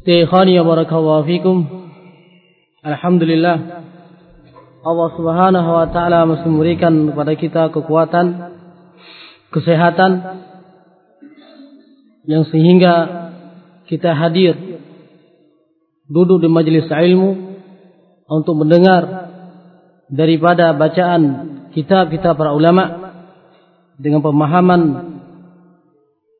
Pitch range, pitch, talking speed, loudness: 160-180 Hz, 170 Hz, 75 wpm, -13 LUFS